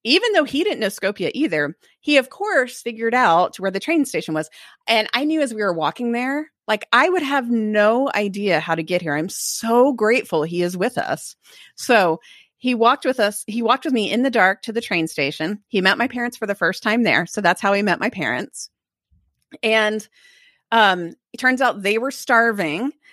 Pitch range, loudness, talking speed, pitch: 195-255 Hz, -19 LUFS, 215 wpm, 225 Hz